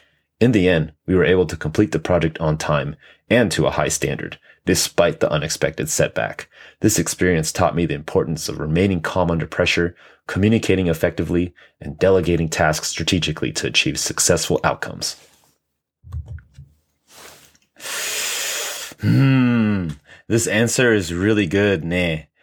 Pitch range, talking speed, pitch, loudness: 80-100 Hz, 130 wpm, 90 Hz, -19 LUFS